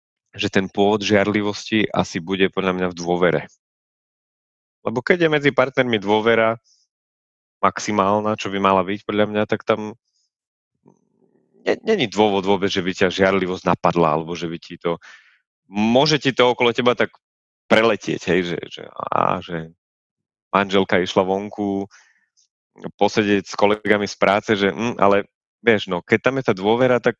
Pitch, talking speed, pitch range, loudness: 100 Hz, 155 wpm, 95-110 Hz, -19 LUFS